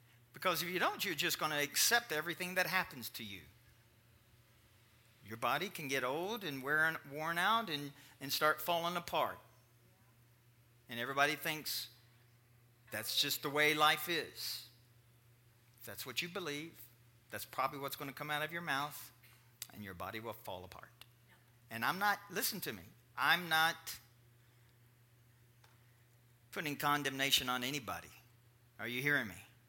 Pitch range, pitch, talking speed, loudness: 120-145 Hz, 120 Hz, 150 wpm, -36 LUFS